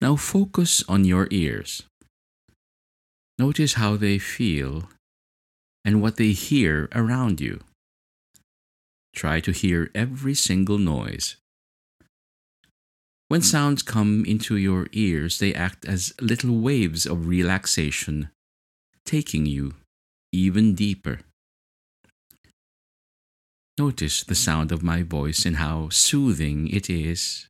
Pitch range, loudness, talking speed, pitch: 75-105 Hz, -22 LUFS, 105 wpm, 90 Hz